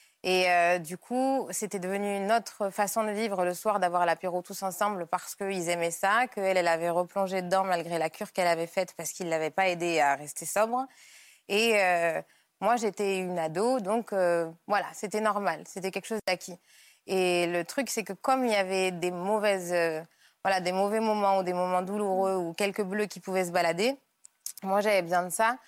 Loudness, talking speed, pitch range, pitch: -28 LUFS, 205 wpm, 180-210 Hz, 190 Hz